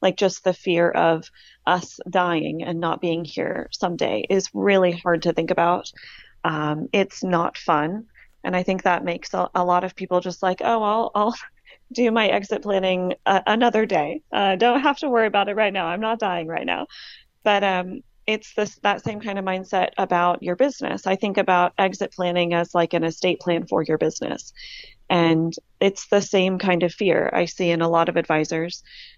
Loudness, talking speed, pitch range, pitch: -22 LUFS, 200 wpm, 170-205 Hz, 185 Hz